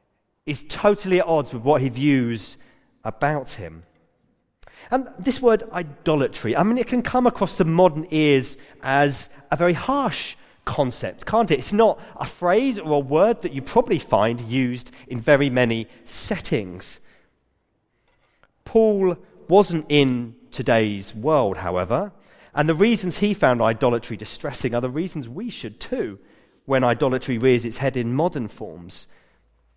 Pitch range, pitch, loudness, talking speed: 120-180 Hz, 145 Hz, -21 LUFS, 145 wpm